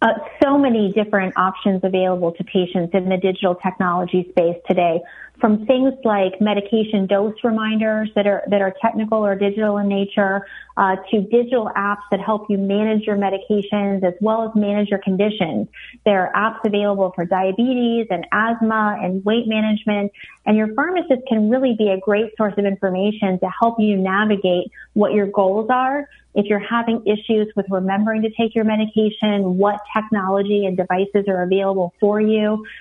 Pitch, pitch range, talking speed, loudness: 205 Hz, 195-220 Hz, 170 wpm, -19 LUFS